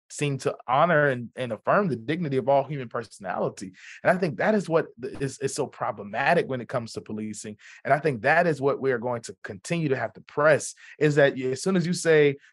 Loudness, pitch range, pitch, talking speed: -25 LUFS, 125-155 Hz, 140 Hz, 235 wpm